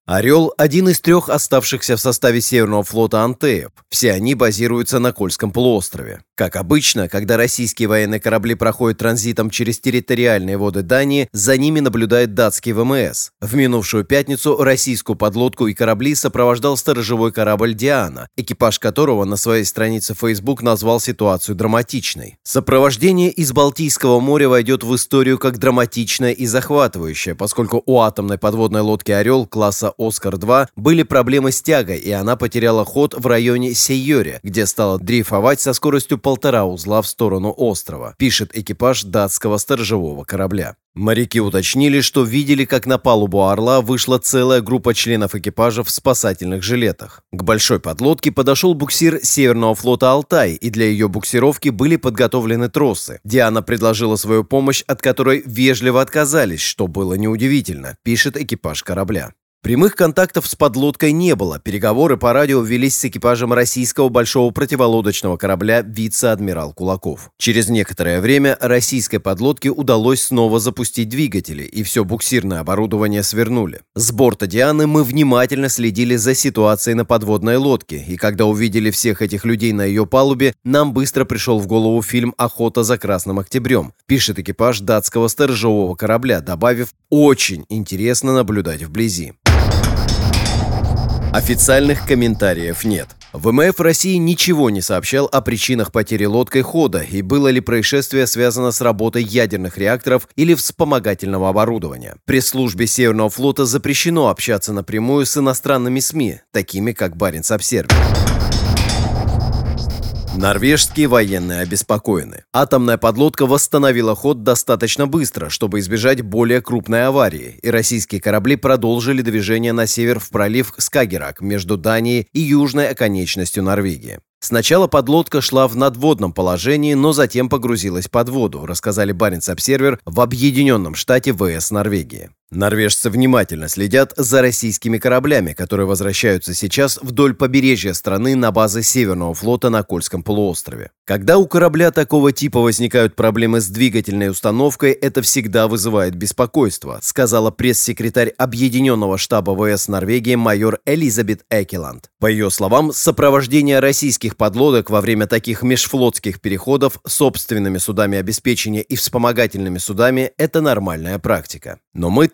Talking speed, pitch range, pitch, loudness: 135 wpm, 105-130 Hz, 115 Hz, -15 LUFS